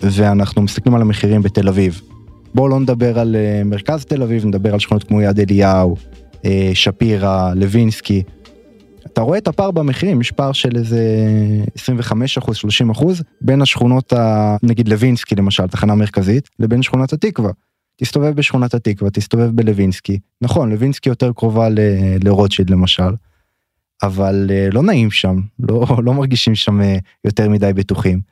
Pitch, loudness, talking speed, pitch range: 110 Hz, -15 LUFS, 140 wpm, 100-125 Hz